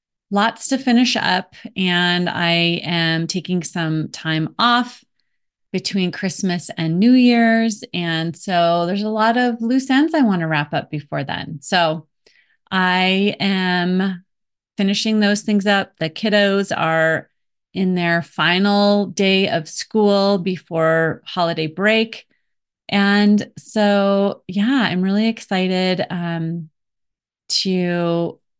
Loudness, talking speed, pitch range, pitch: -18 LUFS, 120 wpm, 170-205 Hz, 185 Hz